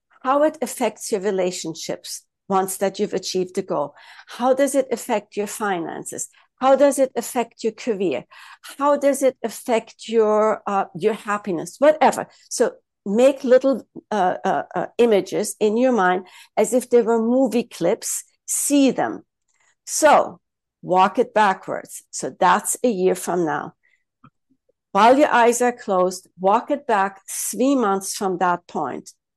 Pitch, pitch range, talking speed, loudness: 230 Hz, 195-260 Hz, 150 wpm, -20 LUFS